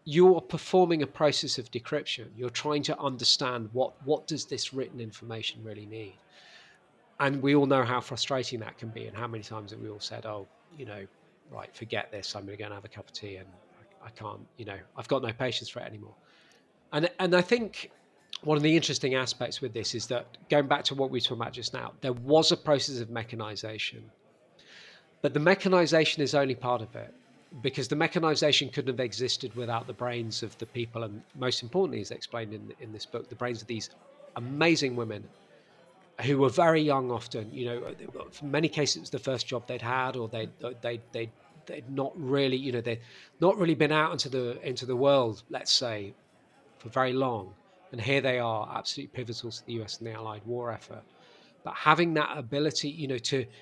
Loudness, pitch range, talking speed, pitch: -29 LUFS, 115-145 Hz, 210 wpm, 125 Hz